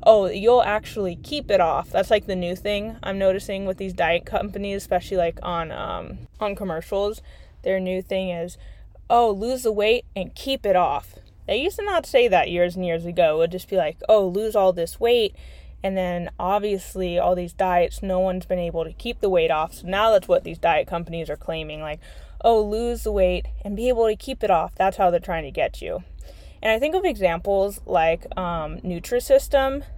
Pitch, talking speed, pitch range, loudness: 195 Hz, 210 wpm, 175-220 Hz, -23 LUFS